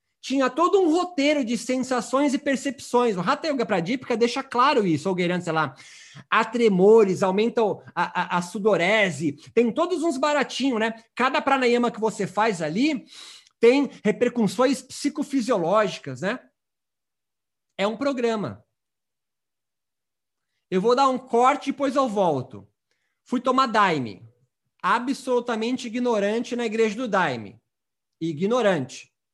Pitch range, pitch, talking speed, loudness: 185-265 Hz, 230 Hz, 130 wpm, -23 LUFS